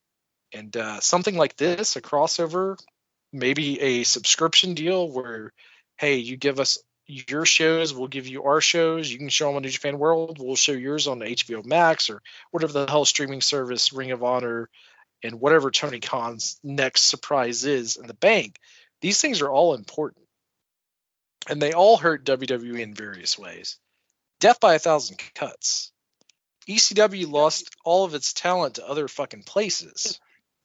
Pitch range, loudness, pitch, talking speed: 130-165 Hz, -22 LUFS, 140 Hz, 165 wpm